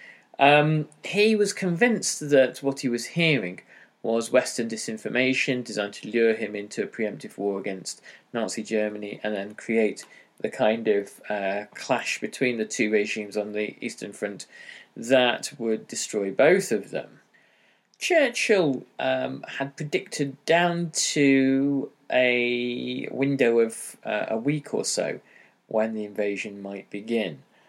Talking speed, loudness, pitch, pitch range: 140 wpm, -25 LUFS, 115 Hz, 105-140 Hz